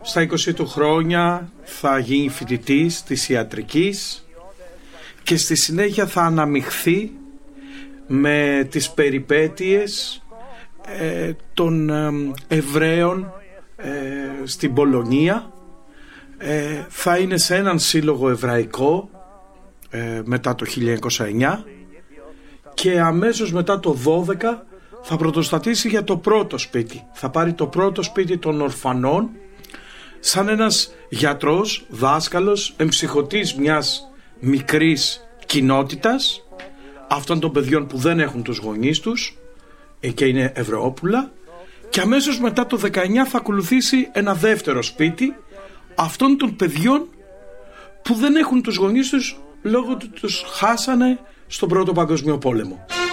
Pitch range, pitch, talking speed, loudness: 145-215 Hz, 170 Hz, 105 wpm, -19 LUFS